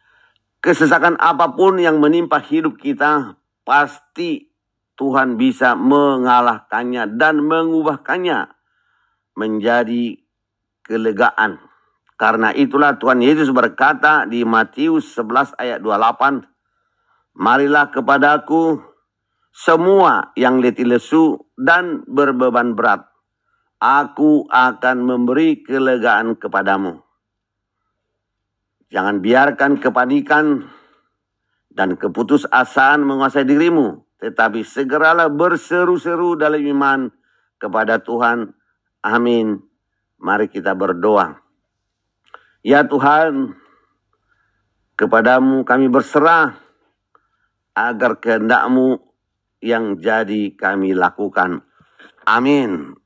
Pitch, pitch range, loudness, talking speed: 135 Hz, 120-160 Hz, -15 LUFS, 80 wpm